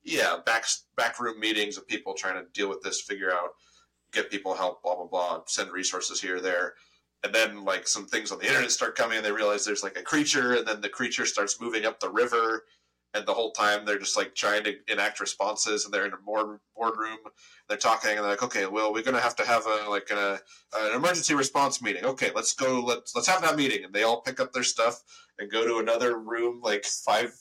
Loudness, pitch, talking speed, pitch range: -27 LUFS, 110 Hz, 245 wpm, 105-125 Hz